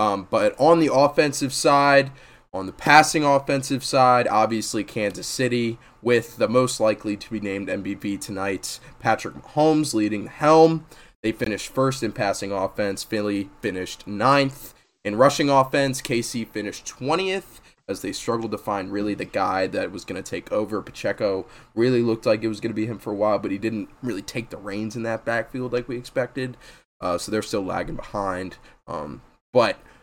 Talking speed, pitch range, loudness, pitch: 180 wpm, 105-135 Hz, -23 LUFS, 115 Hz